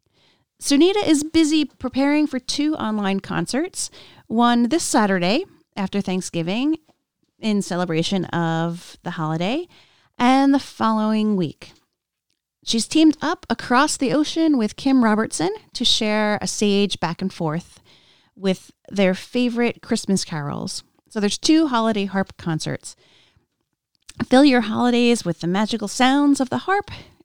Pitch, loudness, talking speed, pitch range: 225 Hz, -20 LUFS, 130 wpm, 190-280 Hz